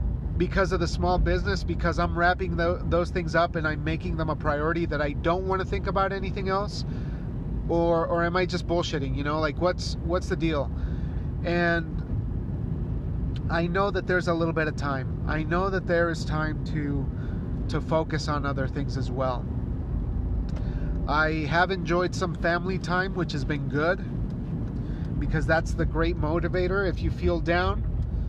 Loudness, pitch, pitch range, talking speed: -27 LUFS, 155 Hz, 140-175 Hz, 175 wpm